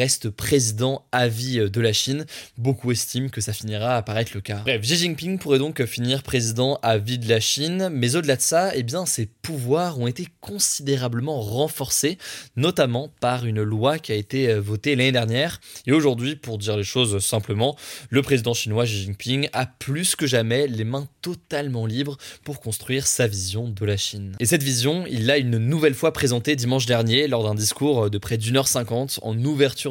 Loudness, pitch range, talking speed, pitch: -22 LUFS, 115-145 Hz, 195 wpm, 125 Hz